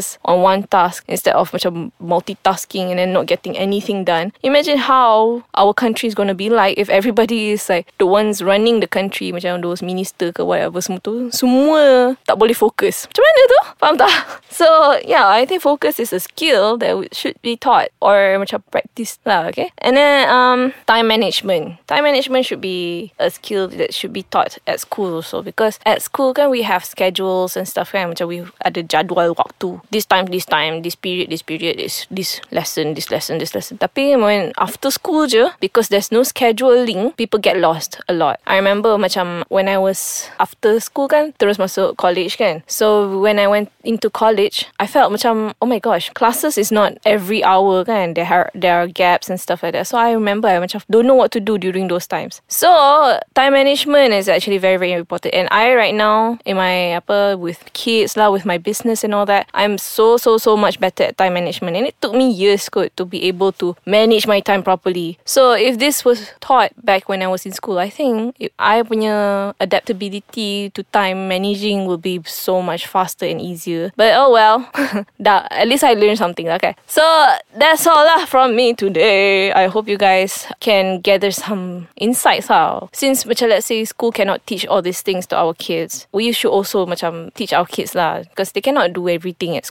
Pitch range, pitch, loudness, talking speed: 185-235 Hz, 205 Hz, -15 LUFS, 205 wpm